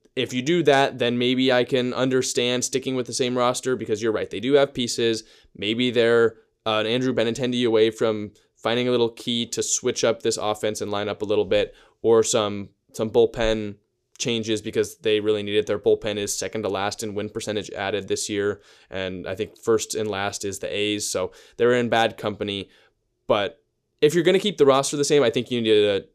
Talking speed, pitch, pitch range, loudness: 220 wpm, 115 Hz, 105-130 Hz, -23 LUFS